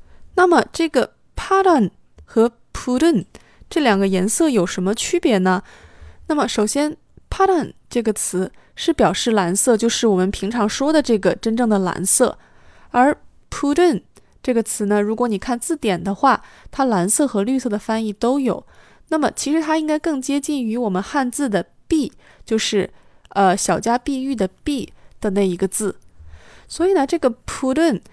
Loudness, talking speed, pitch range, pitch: -19 LUFS, 285 characters per minute, 200-290 Hz, 240 Hz